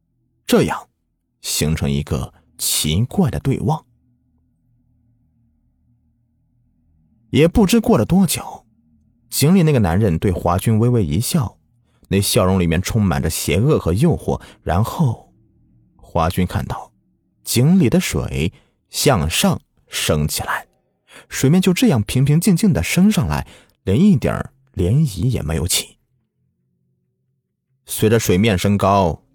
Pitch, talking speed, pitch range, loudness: 110 Hz, 180 characters per minute, 80-130 Hz, -17 LUFS